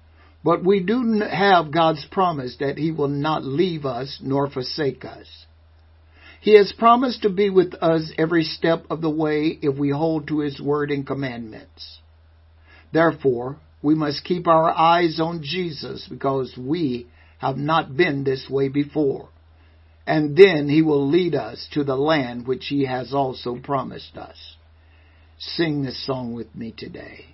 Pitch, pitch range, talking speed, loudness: 140 Hz, 120-160 Hz, 160 wpm, -21 LUFS